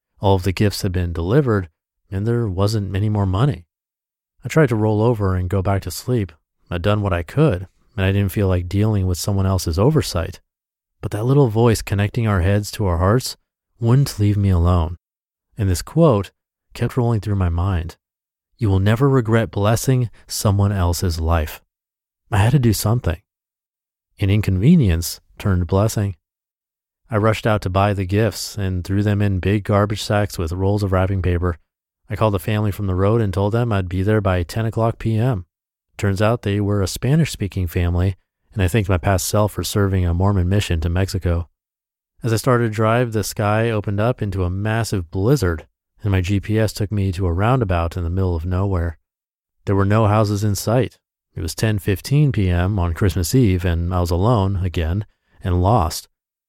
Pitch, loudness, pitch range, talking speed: 100 Hz, -19 LUFS, 90-110 Hz, 190 wpm